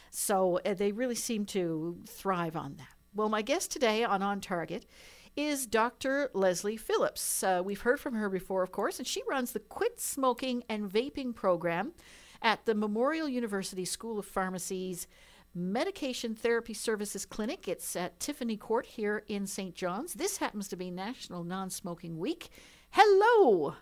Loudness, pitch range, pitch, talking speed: -32 LUFS, 190-265 Hz, 215 Hz, 160 wpm